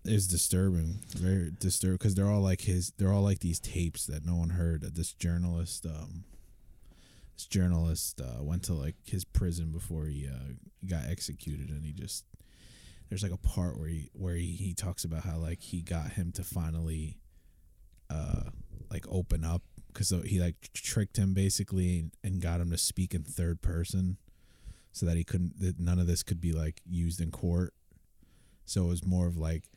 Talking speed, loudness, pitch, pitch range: 185 wpm, -33 LUFS, 85 Hz, 80-95 Hz